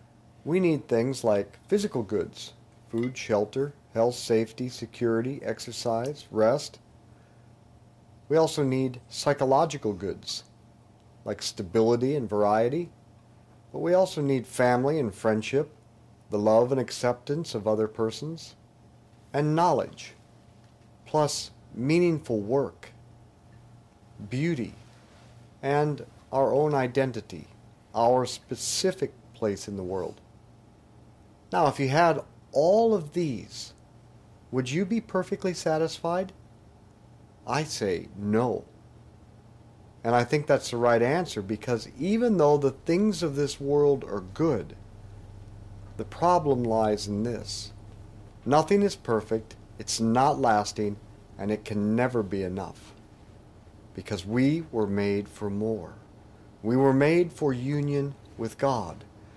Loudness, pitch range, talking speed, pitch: -27 LUFS, 110-140 Hz, 115 wpm, 115 Hz